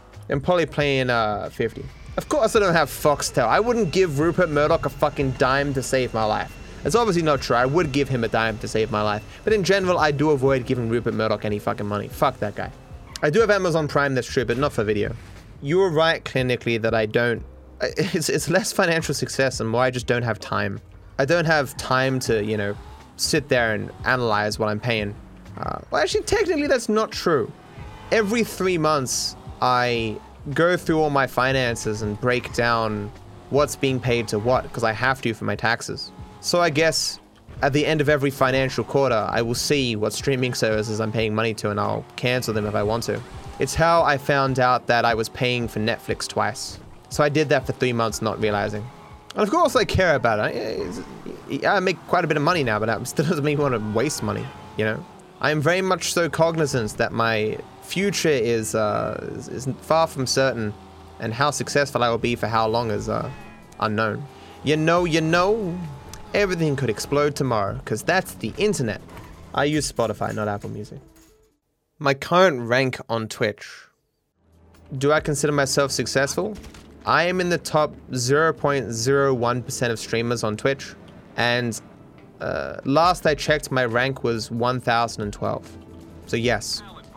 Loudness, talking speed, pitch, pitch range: -22 LUFS, 190 wpm, 125 Hz, 110-150 Hz